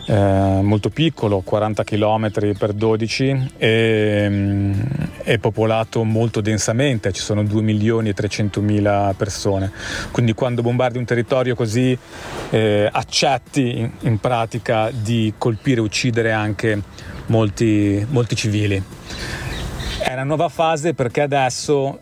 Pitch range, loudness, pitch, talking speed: 105-125 Hz, -19 LUFS, 110 Hz, 125 wpm